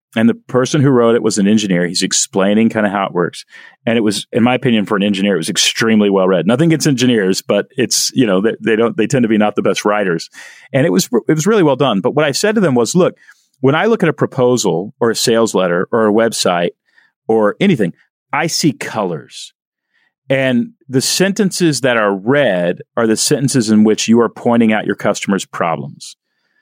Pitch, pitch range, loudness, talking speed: 115 Hz, 105-135 Hz, -14 LUFS, 225 wpm